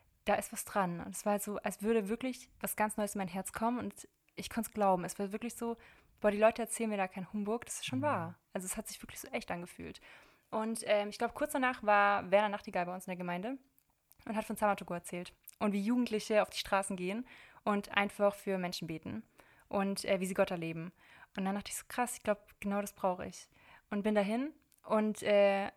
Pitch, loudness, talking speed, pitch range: 205 Hz, -35 LUFS, 240 wpm, 195-220 Hz